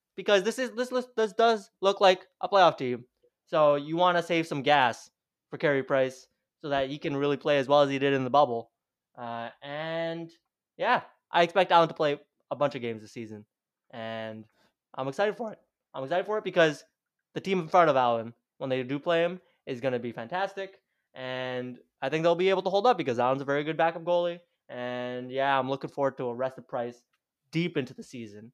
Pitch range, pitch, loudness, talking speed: 130-175 Hz, 145 Hz, -27 LUFS, 220 wpm